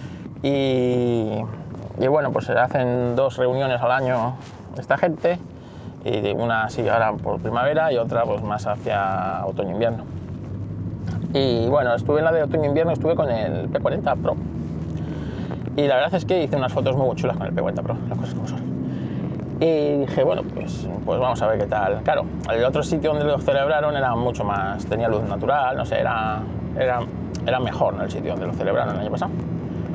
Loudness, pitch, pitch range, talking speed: -22 LUFS, 115 Hz, 95-140 Hz, 190 wpm